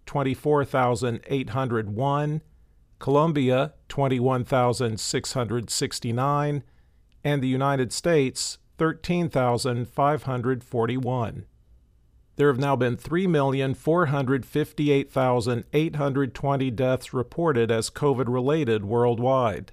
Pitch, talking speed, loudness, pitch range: 130 Hz, 60 wpm, -25 LUFS, 120-145 Hz